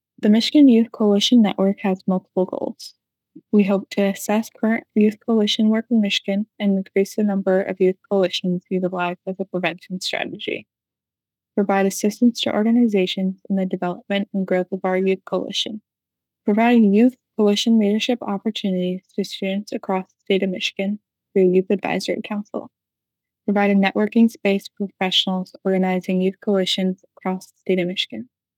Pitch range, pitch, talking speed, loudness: 185-215 Hz, 195 Hz, 155 wpm, -20 LUFS